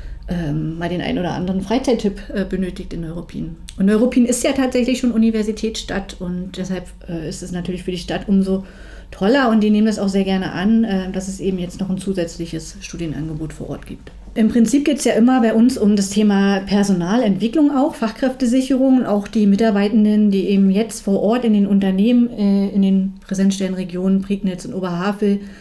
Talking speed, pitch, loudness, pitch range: 180 wpm, 200 Hz, -18 LUFS, 185-225 Hz